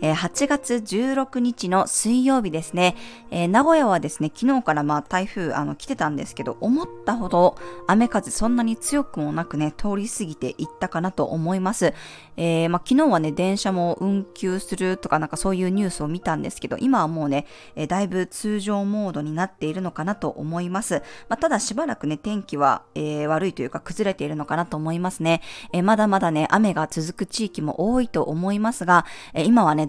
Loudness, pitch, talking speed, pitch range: -23 LUFS, 185 Hz, 395 characters per minute, 160-215 Hz